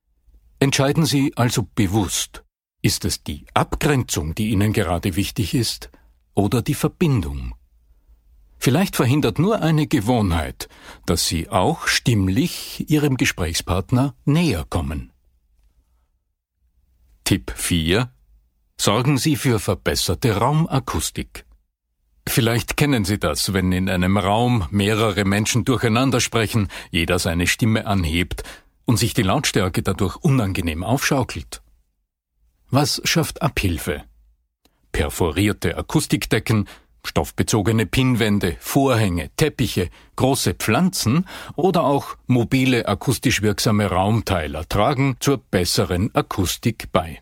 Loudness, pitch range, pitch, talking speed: -20 LUFS, 85-130 Hz, 105 Hz, 105 wpm